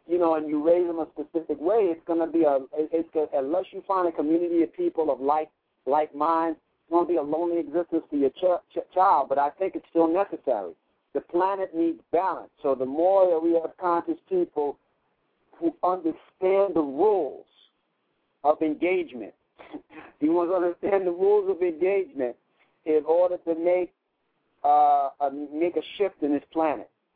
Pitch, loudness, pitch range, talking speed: 165 Hz, -25 LUFS, 155-185 Hz, 185 wpm